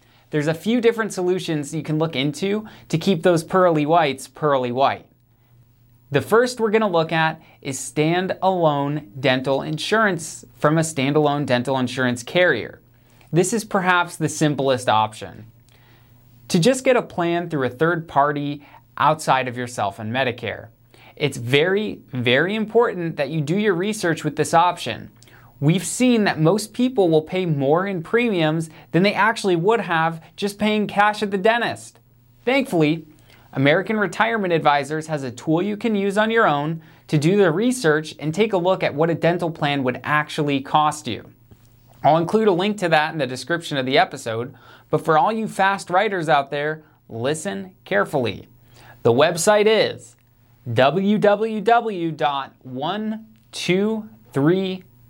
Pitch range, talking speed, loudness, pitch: 130-190 Hz, 155 wpm, -20 LUFS, 155 Hz